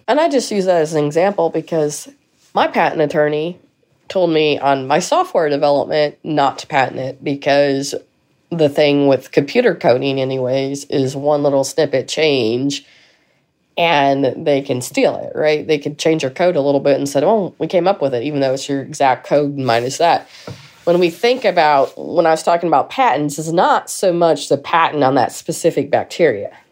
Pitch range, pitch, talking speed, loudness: 140-170 Hz, 150 Hz, 190 wpm, -16 LUFS